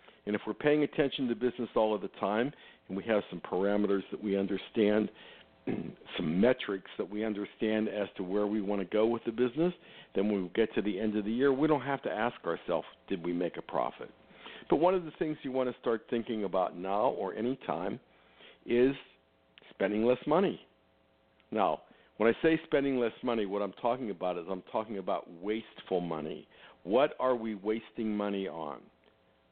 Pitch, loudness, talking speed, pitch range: 105 Hz, -32 LUFS, 195 wpm, 95-120 Hz